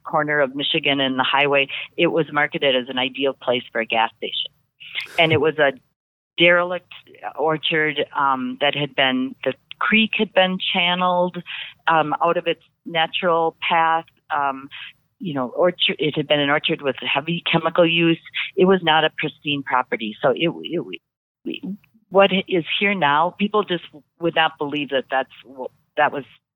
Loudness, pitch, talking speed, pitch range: -20 LUFS, 155 Hz, 165 wpm, 135-170 Hz